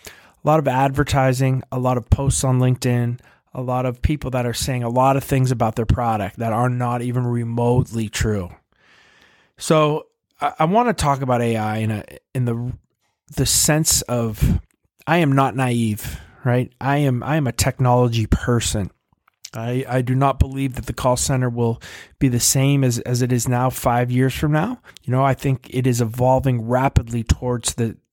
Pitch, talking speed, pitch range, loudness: 125 Hz, 190 wpm, 120-135 Hz, -20 LUFS